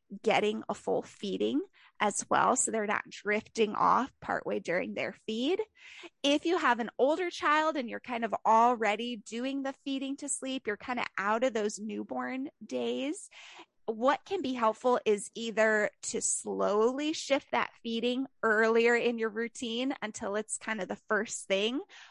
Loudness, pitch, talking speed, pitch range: -31 LUFS, 235 Hz, 165 wpm, 220-275 Hz